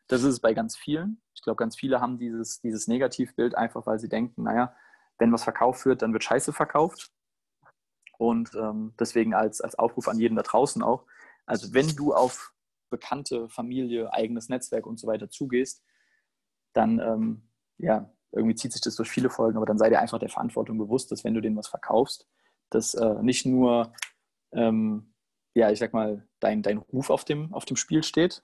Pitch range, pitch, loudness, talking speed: 110-130 Hz, 115 Hz, -27 LUFS, 195 wpm